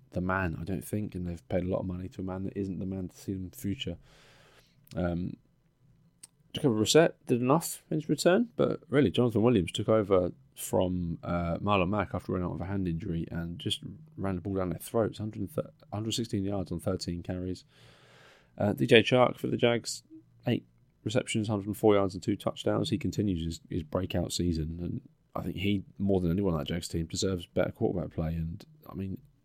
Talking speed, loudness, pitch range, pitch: 210 wpm, -30 LUFS, 90-115 Hz, 95 Hz